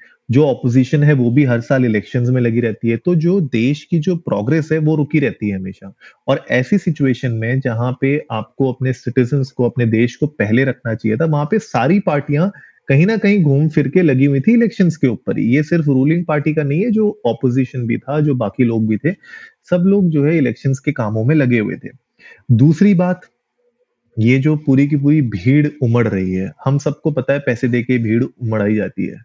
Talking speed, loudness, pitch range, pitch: 215 wpm, -16 LUFS, 120-160 Hz, 140 Hz